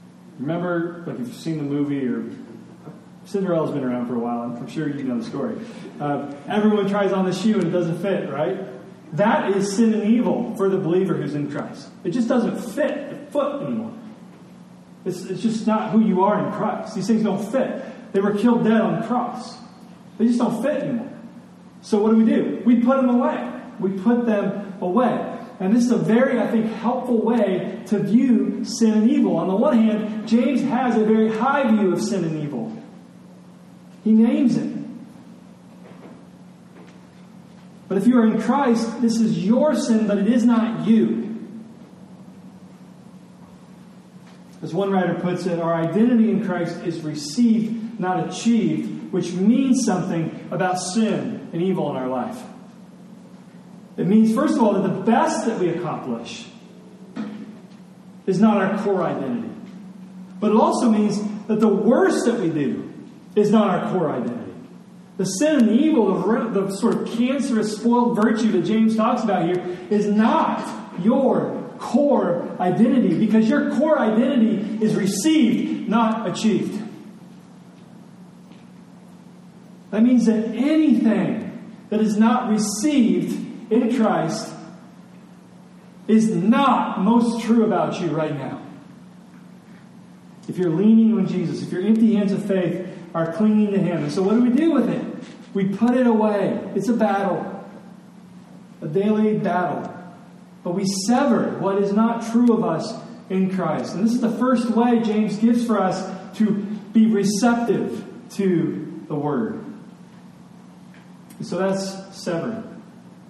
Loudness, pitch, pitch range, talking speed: -20 LUFS, 210 Hz, 190-230 Hz, 160 wpm